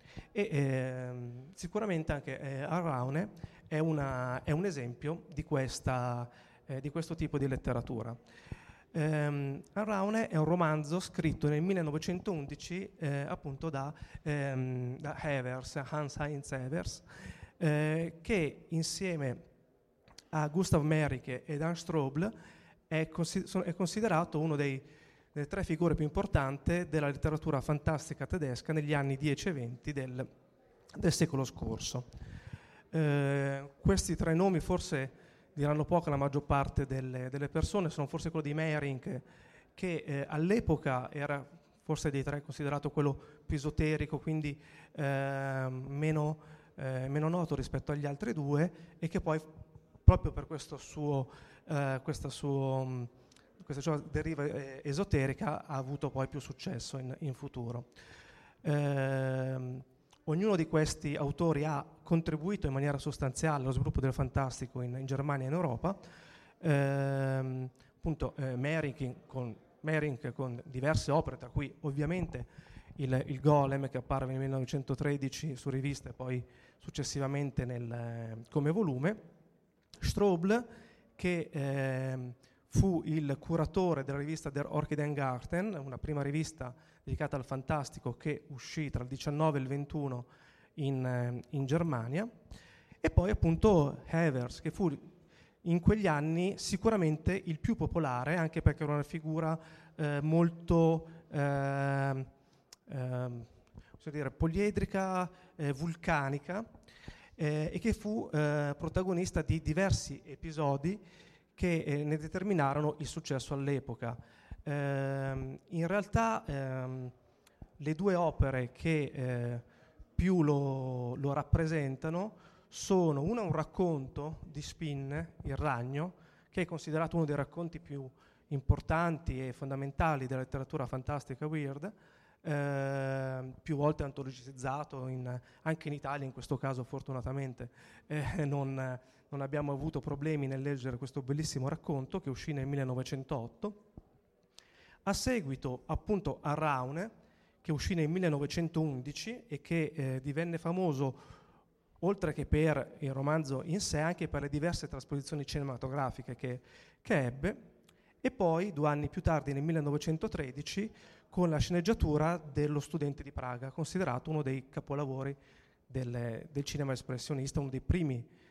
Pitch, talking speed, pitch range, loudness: 145 Hz, 130 wpm, 135-160 Hz, -35 LUFS